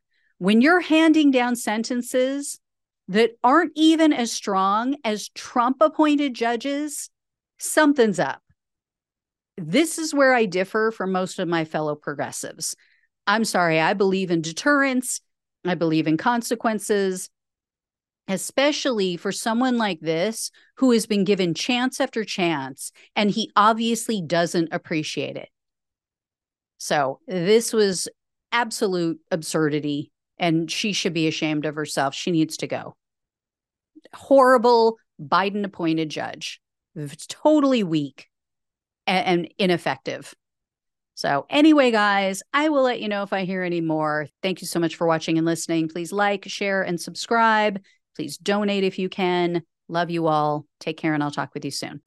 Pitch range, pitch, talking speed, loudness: 165-240 Hz, 195 Hz, 140 wpm, -22 LUFS